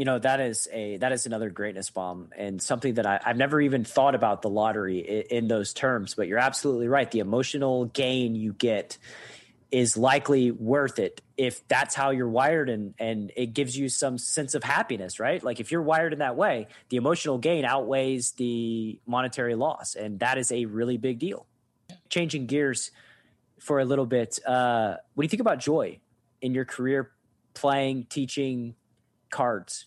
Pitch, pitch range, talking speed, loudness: 125 Hz, 115-135 Hz, 185 wpm, -27 LUFS